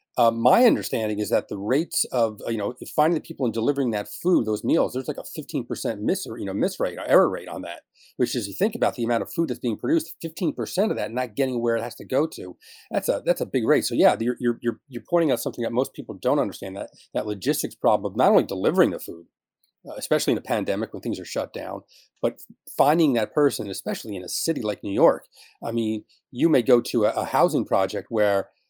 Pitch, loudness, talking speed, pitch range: 120 Hz, -24 LUFS, 255 wpm, 110-145 Hz